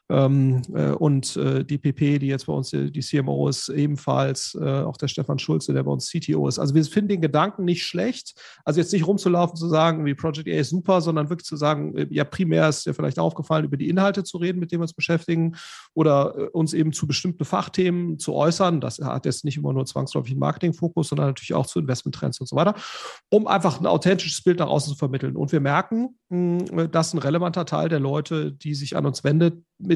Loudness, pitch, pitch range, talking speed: -23 LUFS, 155 Hz, 140-175 Hz, 215 wpm